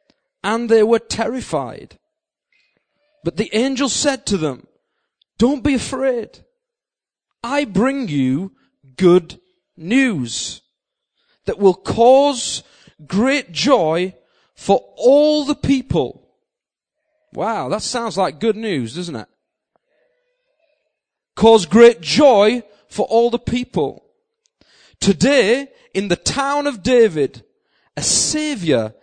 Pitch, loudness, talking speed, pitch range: 245 Hz, -17 LUFS, 105 wpm, 205-295 Hz